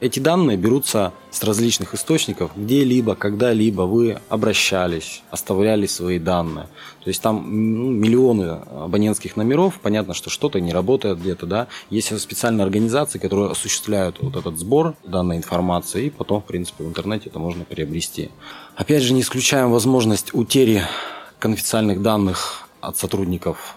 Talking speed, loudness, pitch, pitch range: 140 wpm, -20 LUFS, 105 Hz, 90-120 Hz